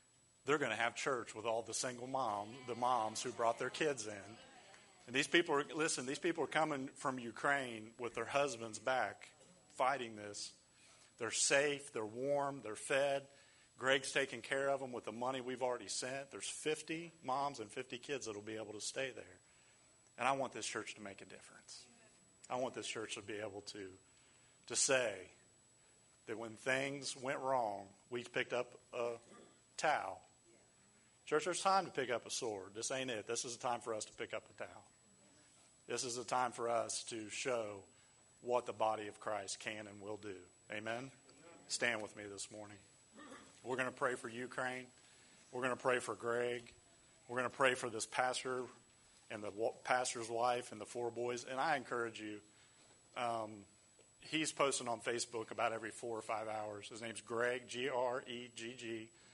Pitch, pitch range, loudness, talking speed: 120 Hz, 110-130 Hz, -40 LUFS, 190 wpm